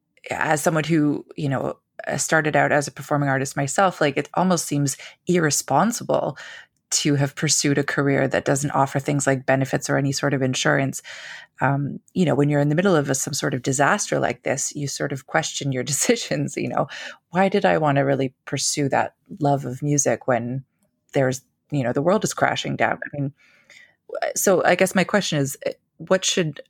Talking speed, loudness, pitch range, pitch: 195 wpm, -22 LUFS, 140-165 Hz, 145 Hz